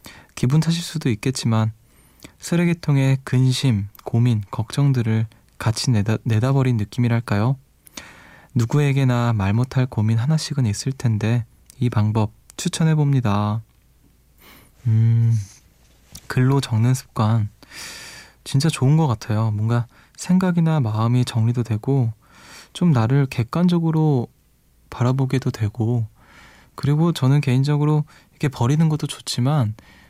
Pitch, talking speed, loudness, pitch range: 125 Hz, 255 characters per minute, -20 LUFS, 110-140 Hz